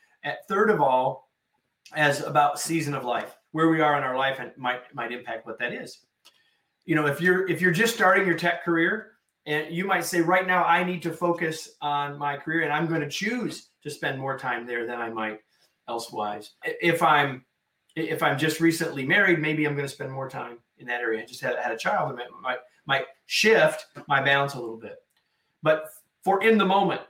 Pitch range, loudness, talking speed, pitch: 135-170 Hz, -25 LUFS, 215 wpm, 150 Hz